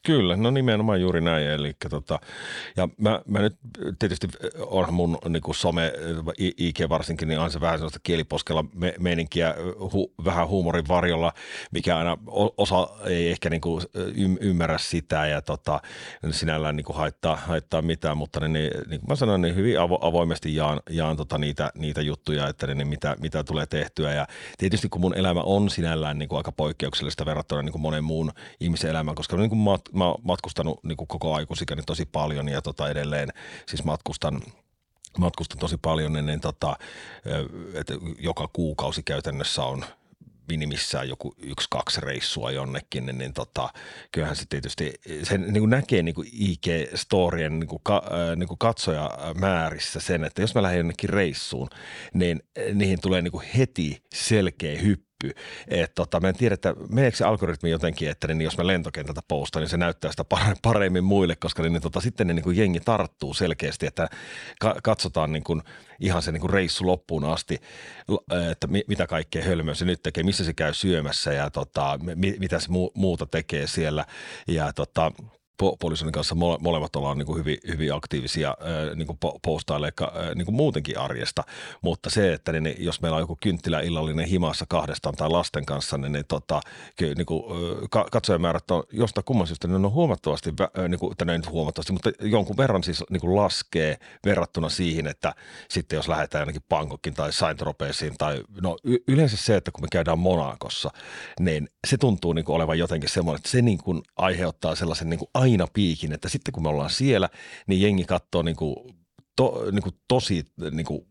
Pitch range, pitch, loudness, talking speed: 80-95 Hz, 85 Hz, -26 LUFS, 170 wpm